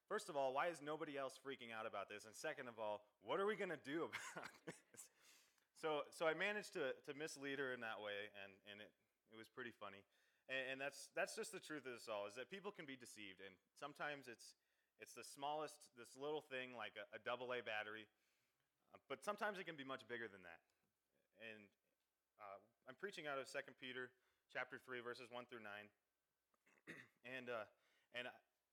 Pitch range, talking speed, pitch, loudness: 110-150 Hz, 205 wpm, 130 Hz, -50 LUFS